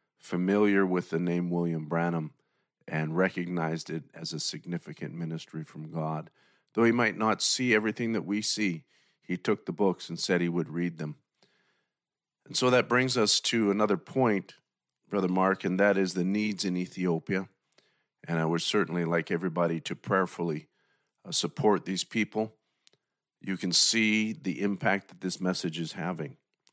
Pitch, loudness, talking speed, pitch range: 95 Hz, -29 LUFS, 160 wpm, 85-105 Hz